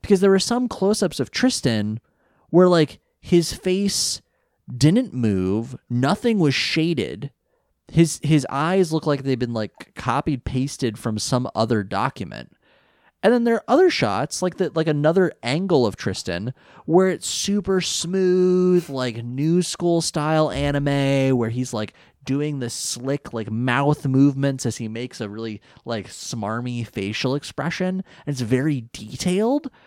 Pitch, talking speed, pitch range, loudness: 140 Hz, 150 wpm, 120-180 Hz, -21 LUFS